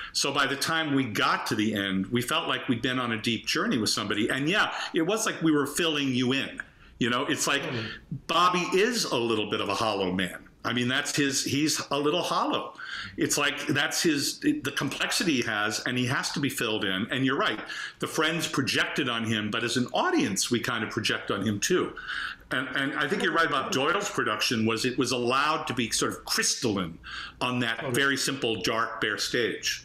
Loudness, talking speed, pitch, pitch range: -27 LUFS, 220 wpm, 135 Hz, 120-155 Hz